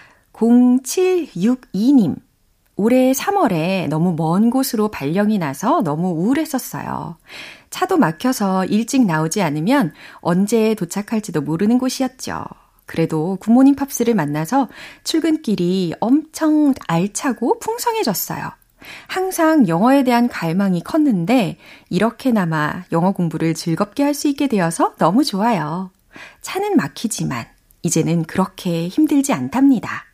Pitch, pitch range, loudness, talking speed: 225 Hz, 180-275 Hz, -18 LUFS, 270 characters per minute